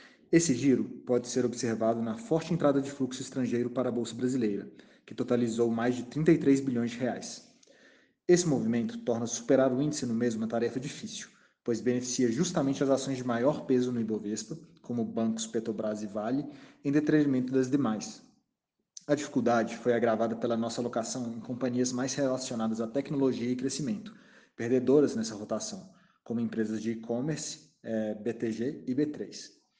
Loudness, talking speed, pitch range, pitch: -30 LUFS, 160 wpm, 115-145 Hz, 125 Hz